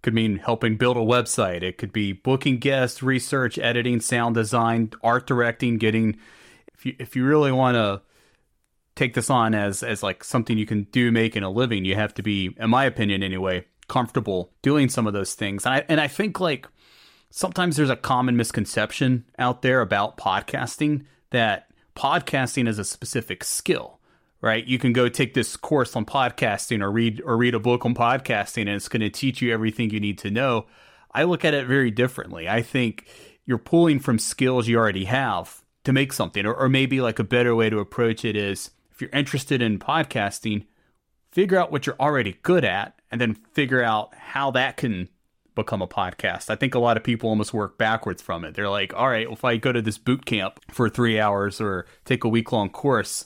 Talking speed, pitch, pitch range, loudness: 205 wpm, 120 Hz, 105-130 Hz, -23 LUFS